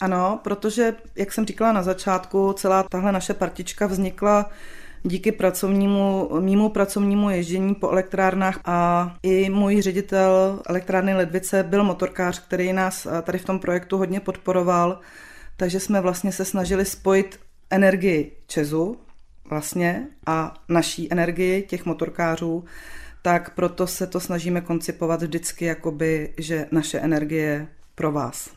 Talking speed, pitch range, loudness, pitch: 130 wpm, 175-195 Hz, -22 LUFS, 185 Hz